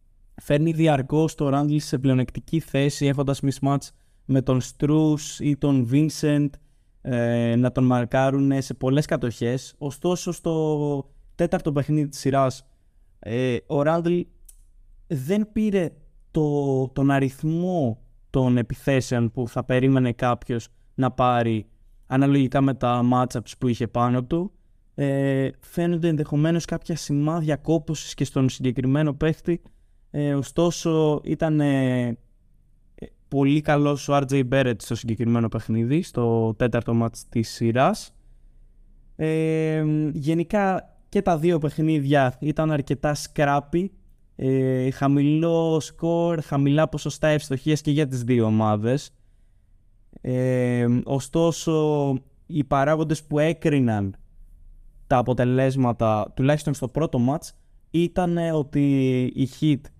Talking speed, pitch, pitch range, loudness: 115 wpm, 140 Hz, 120-155 Hz, -23 LUFS